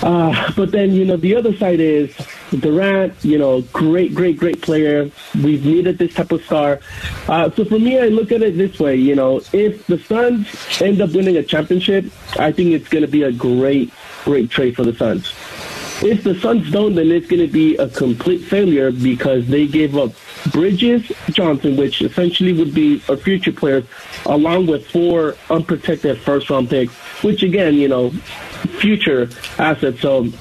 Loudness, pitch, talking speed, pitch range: -16 LUFS, 165 Hz, 185 wpm, 145-195 Hz